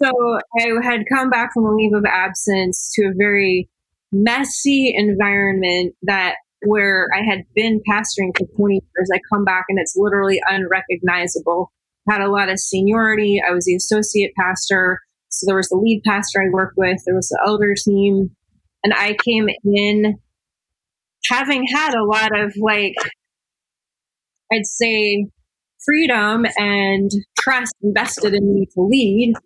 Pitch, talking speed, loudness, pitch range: 205 Hz, 155 wpm, -17 LUFS, 190-220 Hz